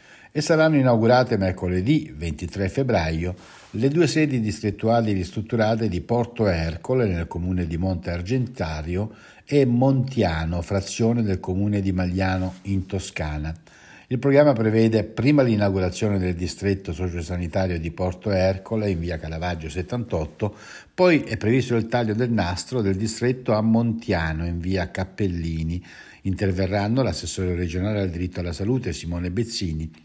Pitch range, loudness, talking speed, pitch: 90-115 Hz, -23 LUFS, 130 wpm, 95 Hz